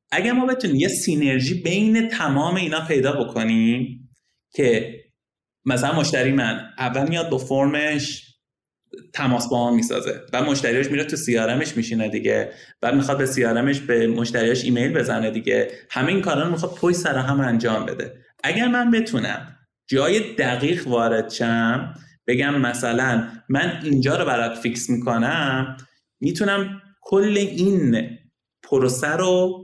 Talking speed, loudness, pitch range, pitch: 135 wpm, -21 LUFS, 120-165 Hz, 135 Hz